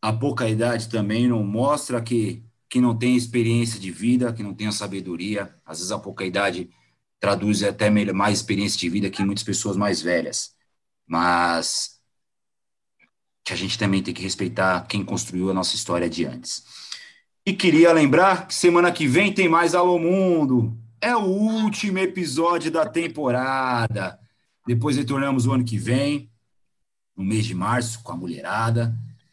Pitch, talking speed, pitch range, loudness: 115 Hz, 165 wpm, 100-140 Hz, -22 LUFS